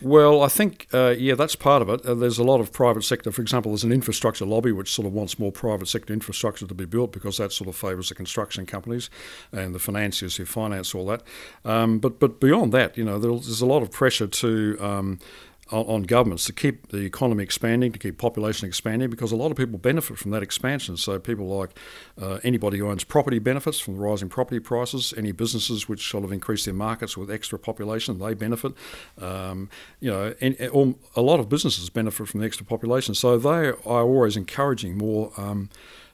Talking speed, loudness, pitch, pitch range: 220 wpm, -24 LUFS, 110 Hz, 100-125 Hz